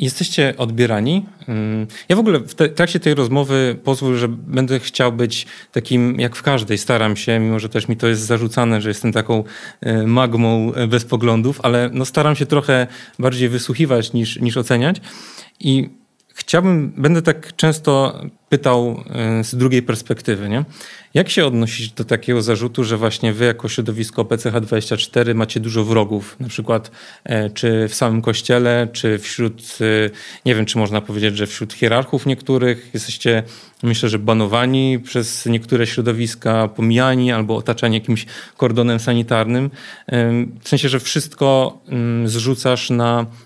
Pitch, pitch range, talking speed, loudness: 120 Hz, 115-130 Hz, 145 wpm, -17 LUFS